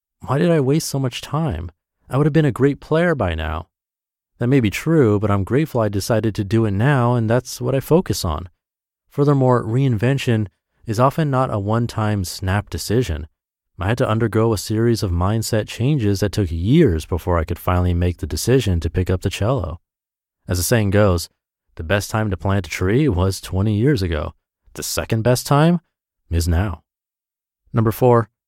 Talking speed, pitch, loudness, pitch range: 195 wpm, 105 Hz, -19 LUFS, 90-125 Hz